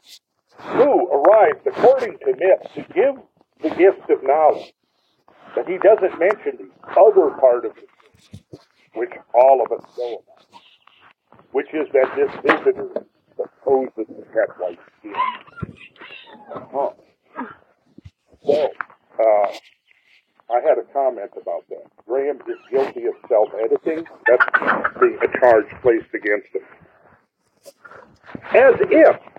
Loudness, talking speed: -18 LUFS, 115 wpm